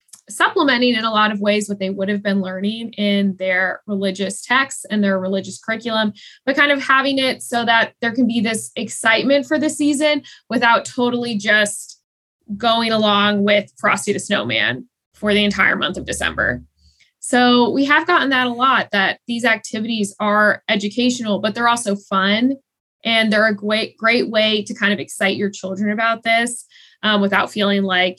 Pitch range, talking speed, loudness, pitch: 200-240 Hz, 180 wpm, -17 LUFS, 220 Hz